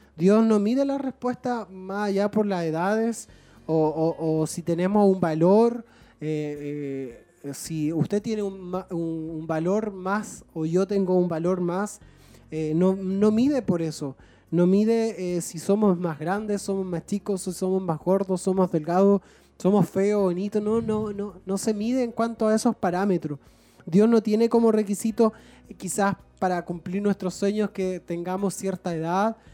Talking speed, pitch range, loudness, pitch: 170 wpm, 170-210 Hz, -25 LUFS, 190 Hz